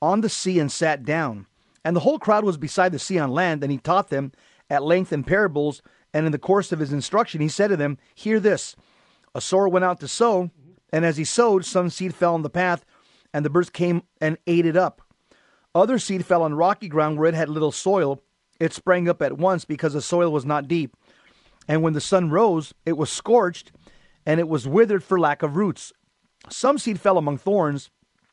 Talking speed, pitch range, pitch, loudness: 220 wpm, 150-190 Hz, 170 Hz, -22 LUFS